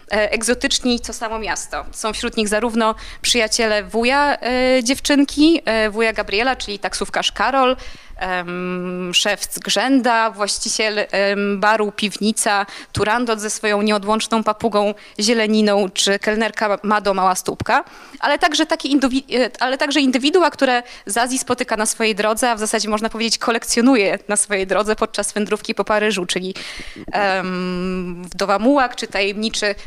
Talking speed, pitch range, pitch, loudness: 140 wpm, 205-245 Hz, 220 Hz, -18 LUFS